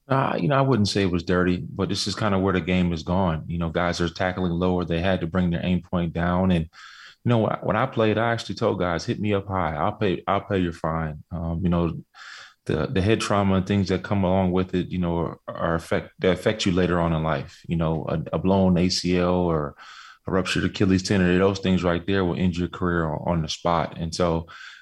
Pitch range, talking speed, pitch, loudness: 85-95 Hz, 245 wpm, 90 Hz, -24 LUFS